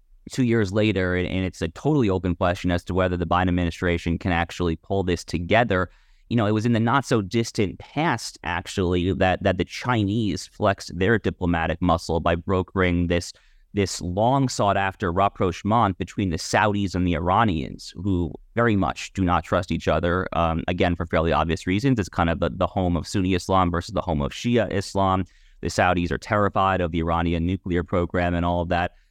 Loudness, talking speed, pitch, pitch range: -23 LUFS, 195 wpm, 90 Hz, 85-100 Hz